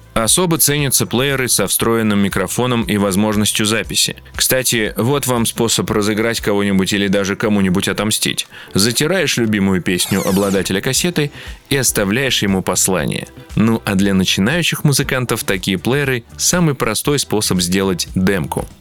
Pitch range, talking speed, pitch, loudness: 100-130 Hz, 130 wpm, 110 Hz, -15 LUFS